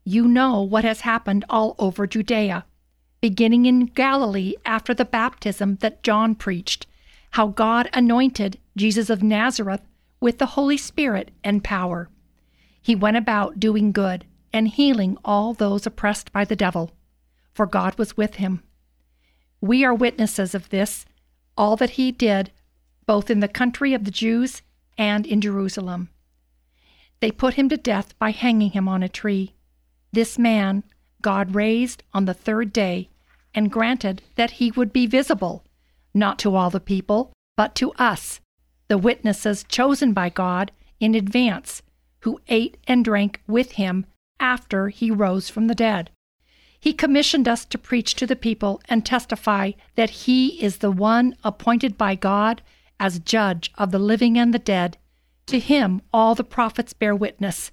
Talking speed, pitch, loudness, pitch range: 160 wpm, 215 Hz, -21 LUFS, 195-235 Hz